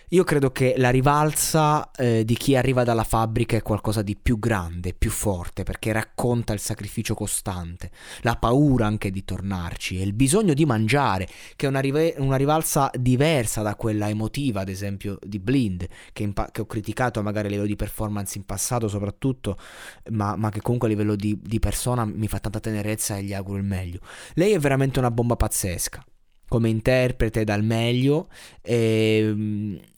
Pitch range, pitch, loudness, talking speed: 100-125 Hz, 110 Hz, -23 LUFS, 180 wpm